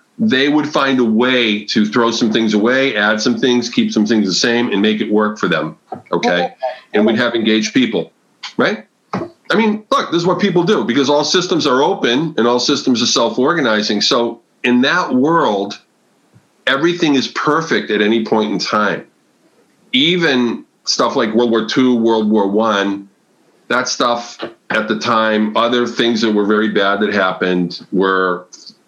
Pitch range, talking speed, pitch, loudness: 105-125 Hz, 175 wpm, 115 Hz, -15 LUFS